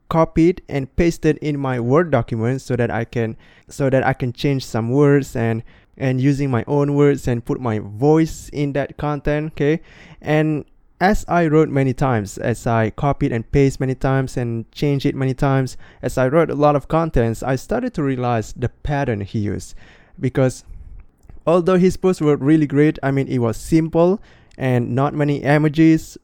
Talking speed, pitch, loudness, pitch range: 185 wpm, 140 Hz, -19 LUFS, 125-150 Hz